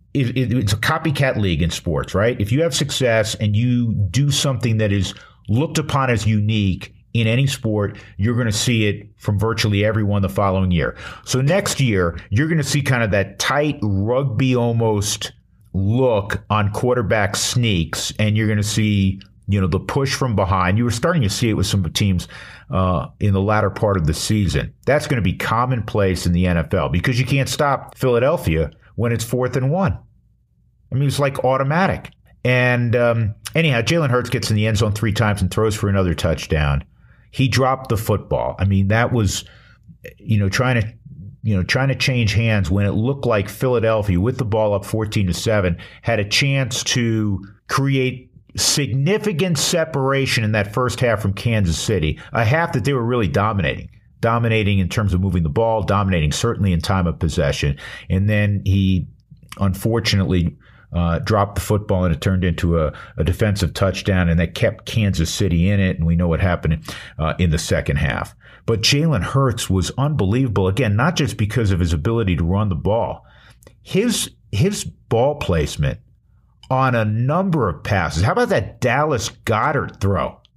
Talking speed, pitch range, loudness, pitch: 185 wpm, 95-125 Hz, -19 LUFS, 110 Hz